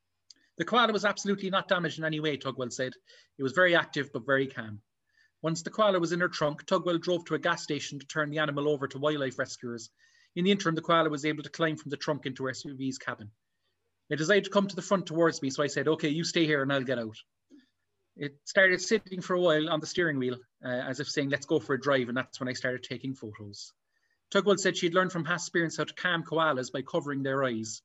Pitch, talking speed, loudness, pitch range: 155 Hz, 250 wpm, -29 LUFS, 135-175 Hz